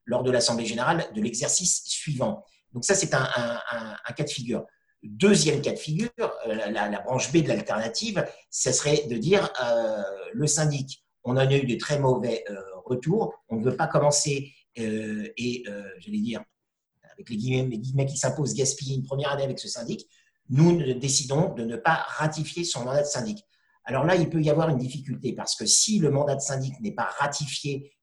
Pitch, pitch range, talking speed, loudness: 145 Hz, 130-175 Hz, 205 wpm, -26 LUFS